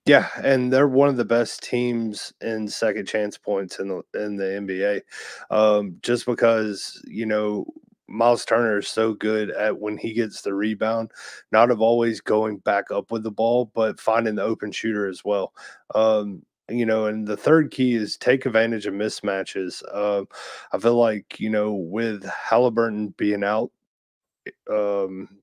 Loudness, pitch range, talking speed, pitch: -23 LUFS, 105-115 Hz, 175 wpm, 110 Hz